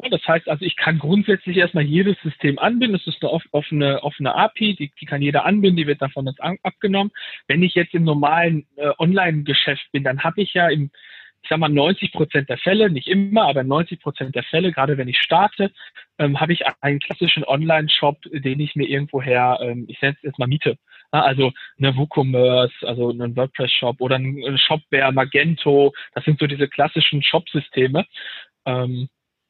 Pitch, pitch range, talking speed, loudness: 145 Hz, 135-170 Hz, 185 wpm, -19 LUFS